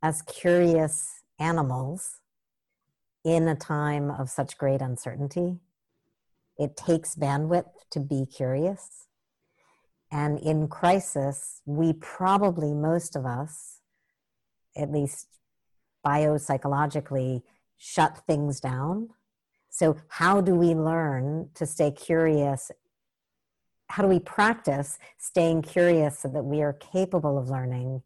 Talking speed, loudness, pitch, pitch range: 110 wpm, -26 LUFS, 155 Hz, 140-170 Hz